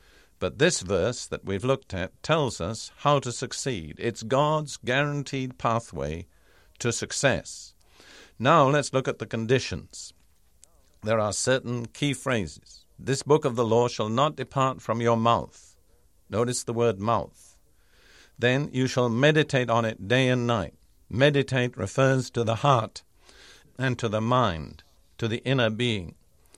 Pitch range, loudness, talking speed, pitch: 95-130 Hz, -26 LUFS, 150 wpm, 115 Hz